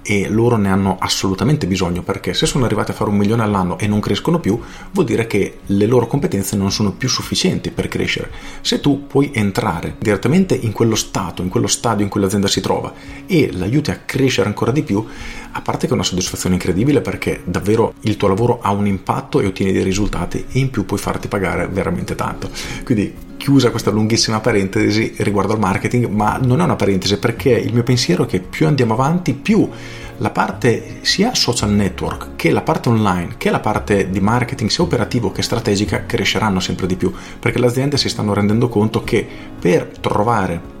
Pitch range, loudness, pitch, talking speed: 95-120 Hz, -17 LUFS, 105 Hz, 200 wpm